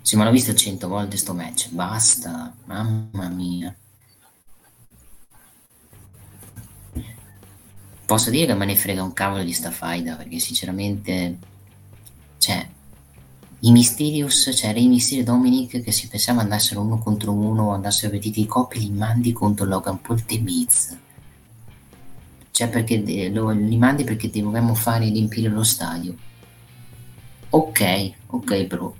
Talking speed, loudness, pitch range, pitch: 130 wpm, -20 LUFS, 95-115 Hz, 105 Hz